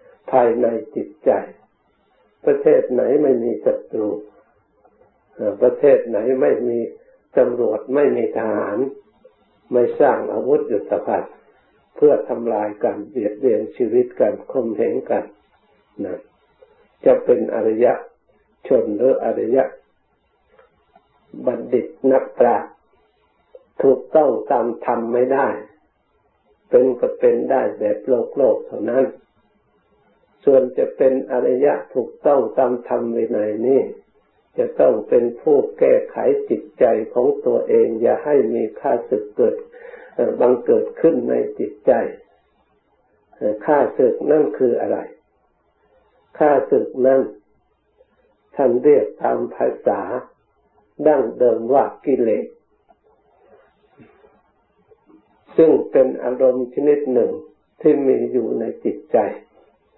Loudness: -18 LUFS